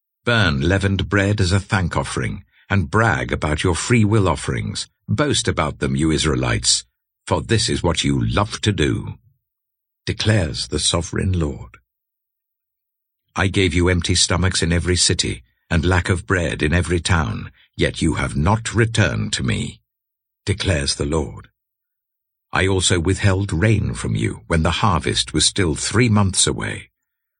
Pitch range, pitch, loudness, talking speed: 80-105 Hz, 95 Hz, -19 LUFS, 155 wpm